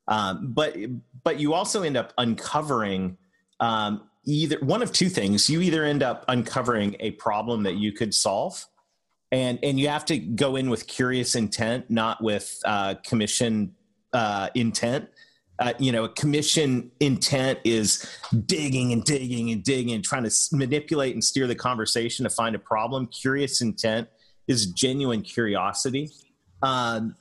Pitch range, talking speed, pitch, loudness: 110-140 Hz, 155 wpm, 125 Hz, -25 LUFS